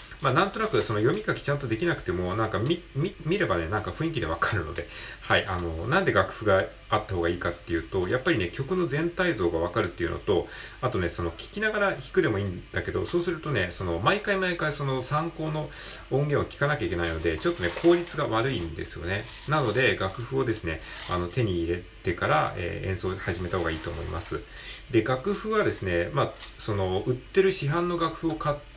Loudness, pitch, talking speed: -27 LUFS, 115 Hz, 440 characters per minute